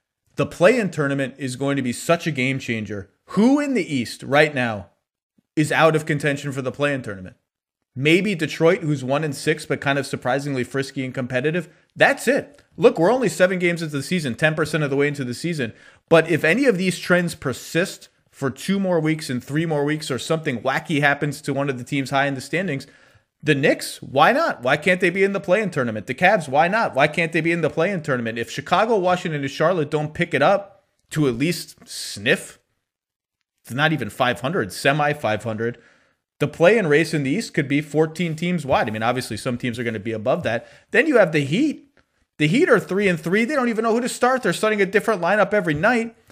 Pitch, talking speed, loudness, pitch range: 150 Hz, 225 wpm, -21 LUFS, 135-175 Hz